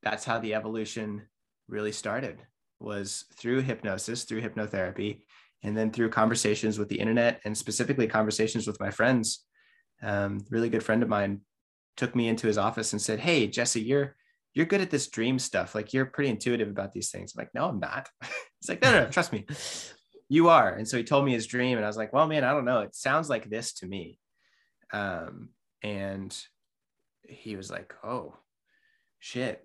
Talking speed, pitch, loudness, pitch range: 195 wpm, 110 Hz, -28 LUFS, 105-125 Hz